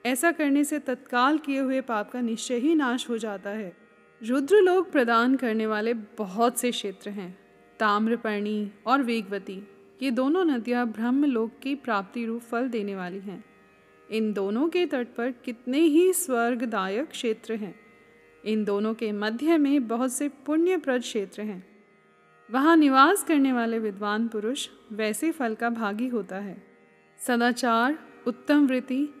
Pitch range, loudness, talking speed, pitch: 210-270 Hz, -26 LUFS, 150 wpm, 235 Hz